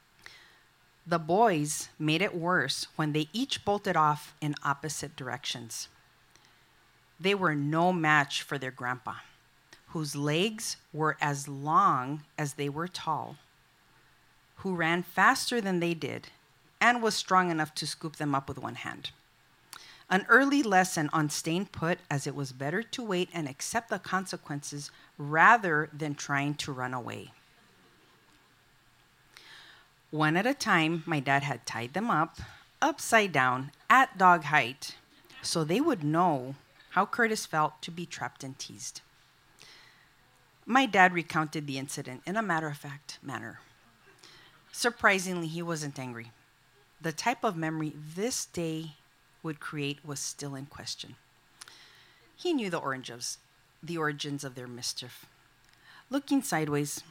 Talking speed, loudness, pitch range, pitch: 140 wpm, -29 LUFS, 140-175 Hz, 155 Hz